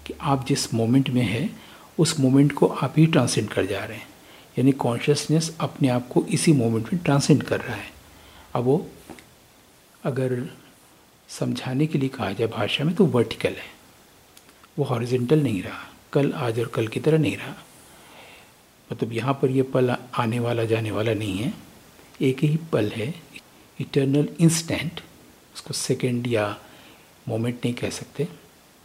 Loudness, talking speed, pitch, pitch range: -23 LUFS, 160 wpm, 130 Hz, 115-145 Hz